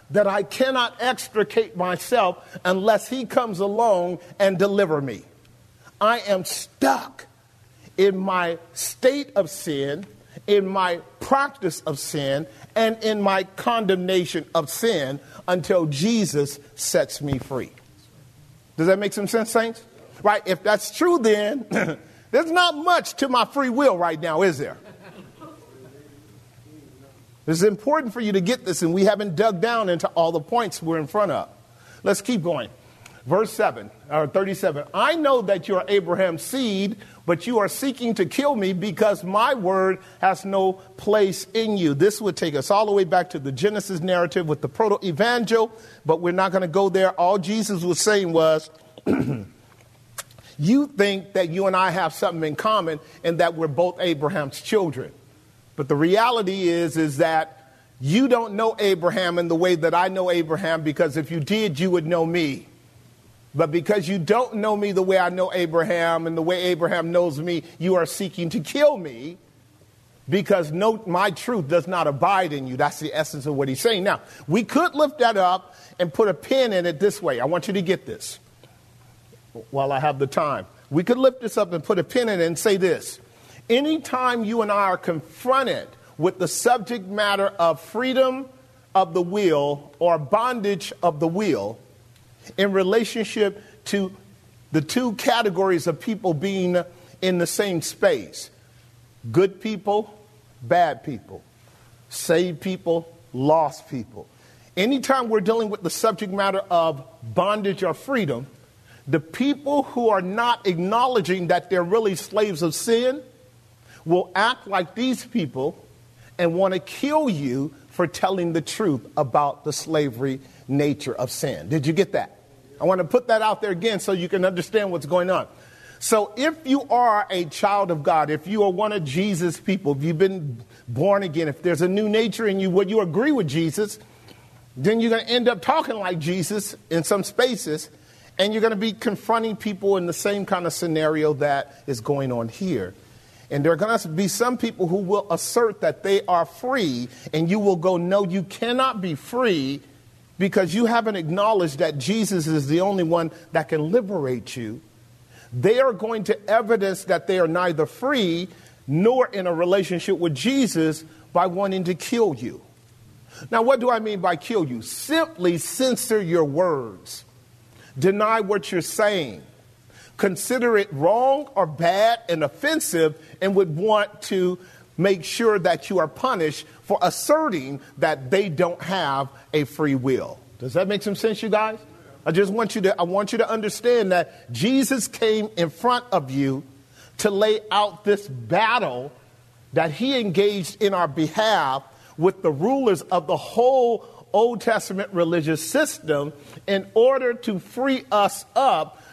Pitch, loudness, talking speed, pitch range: 185 Hz, -22 LUFS, 170 wpm, 155-210 Hz